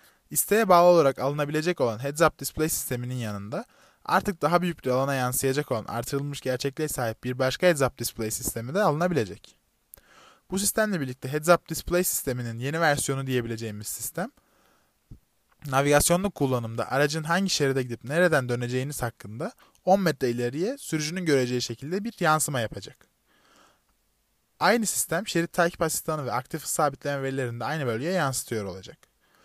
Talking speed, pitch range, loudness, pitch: 145 wpm, 125-175 Hz, -26 LUFS, 145 Hz